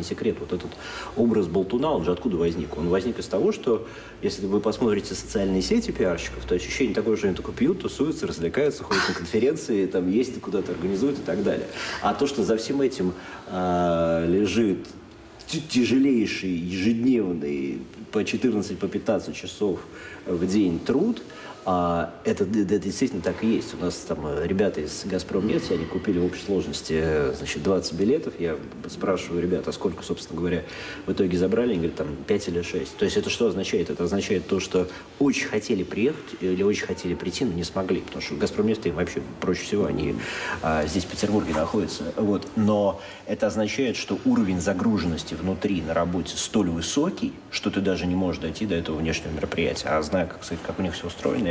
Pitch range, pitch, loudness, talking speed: 85-105 Hz, 90 Hz, -25 LUFS, 180 wpm